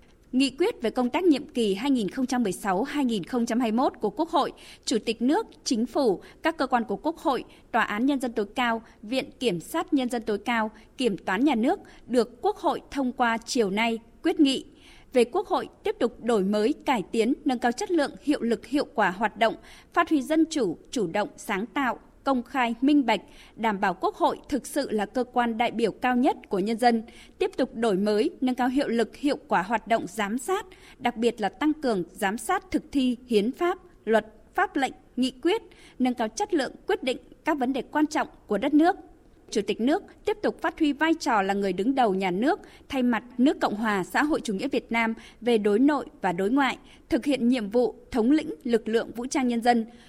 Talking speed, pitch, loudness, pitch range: 220 wpm, 250 Hz, -26 LUFS, 225-300 Hz